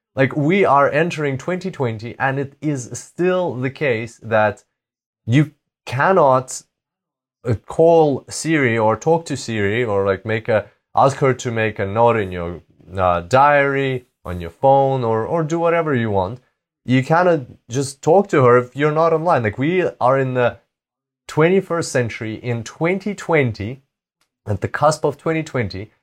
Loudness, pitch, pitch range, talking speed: -18 LUFS, 130 Hz, 115-155 Hz, 155 wpm